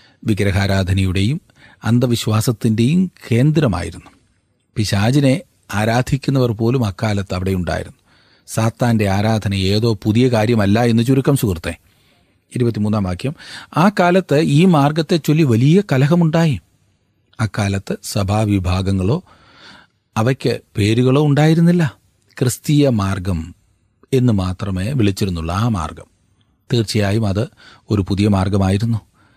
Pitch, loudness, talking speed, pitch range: 110 Hz, -17 LUFS, 90 wpm, 100-130 Hz